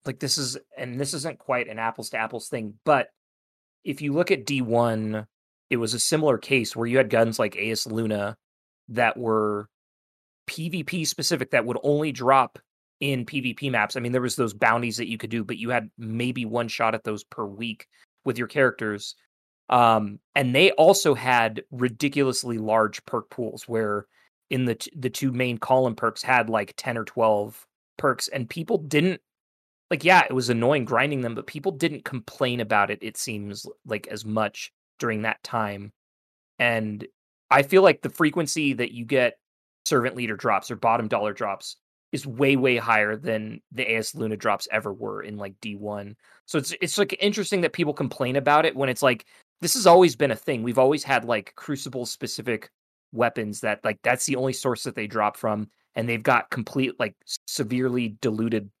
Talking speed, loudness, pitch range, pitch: 190 wpm, -24 LUFS, 110-135 Hz, 120 Hz